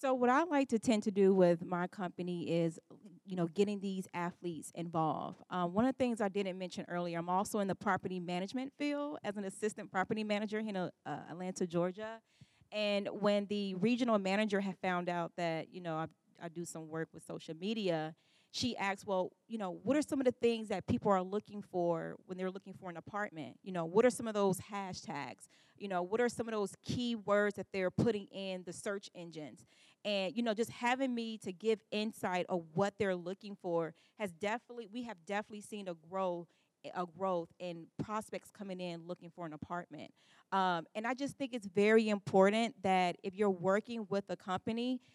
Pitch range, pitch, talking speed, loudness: 175-215 Hz, 195 Hz, 205 wpm, -36 LUFS